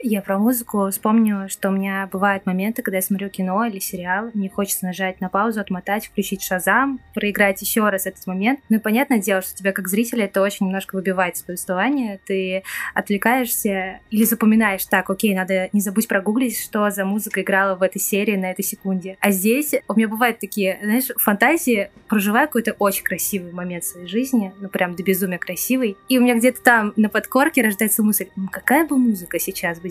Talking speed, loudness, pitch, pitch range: 195 wpm, -20 LUFS, 200 Hz, 190-225 Hz